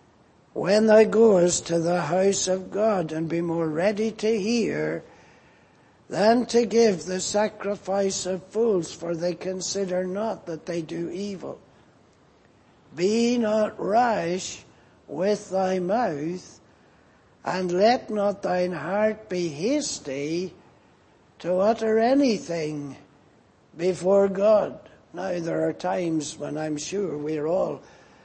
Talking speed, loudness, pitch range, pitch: 120 wpm, -24 LUFS, 170-215 Hz, 185 Hz